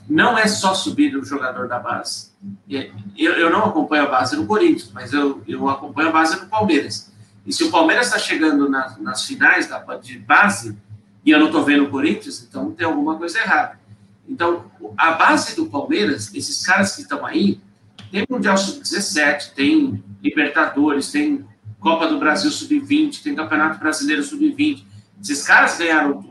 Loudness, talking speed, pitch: -18 LUFS, 175 wpm, 155 Hz